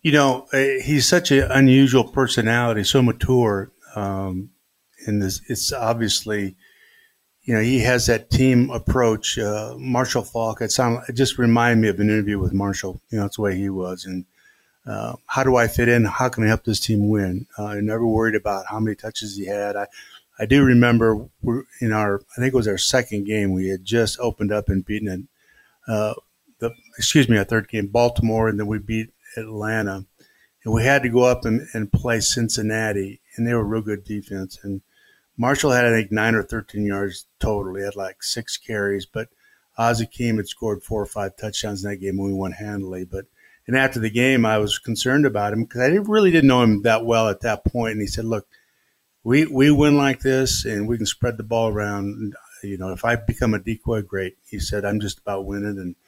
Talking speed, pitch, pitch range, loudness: 215 wpm, 110 Hz, 100-120 Hz, -21 LUFS